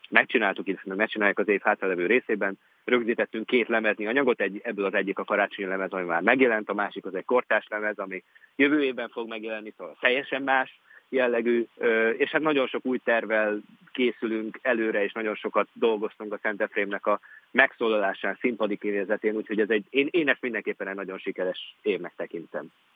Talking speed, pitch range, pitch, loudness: 170 wpm, 100-125 Hz, 110 Hz, -26 LUFS